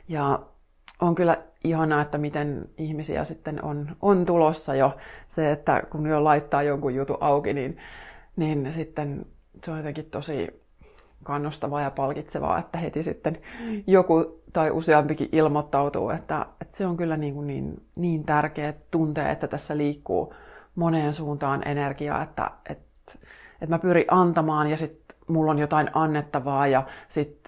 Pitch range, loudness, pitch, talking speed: 145-160 Hz, -25 LUFS, 150 Hz, 150 wpm